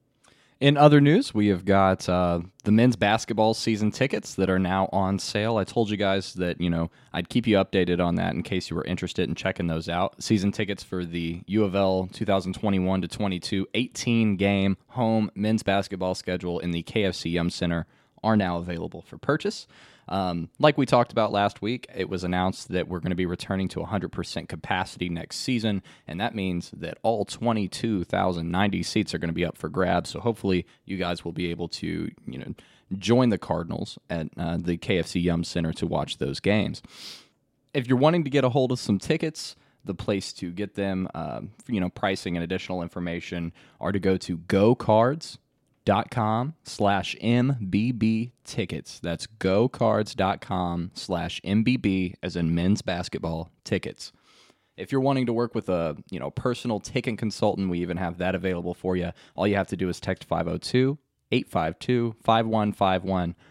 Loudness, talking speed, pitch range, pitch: -26 LUFS, 180 wpm, 90-115 Hz, 95 Hz